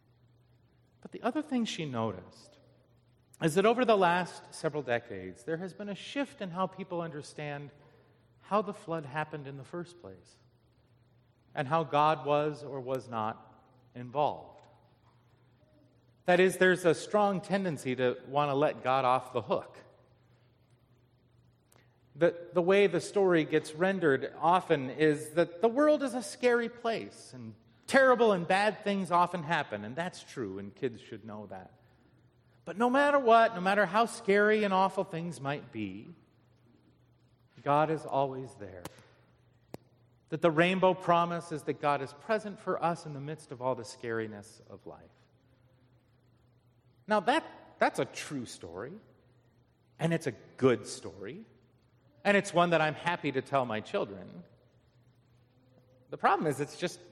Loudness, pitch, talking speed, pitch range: -30 LUFS, 145 Hz, 155 wpm, 120-175 Hz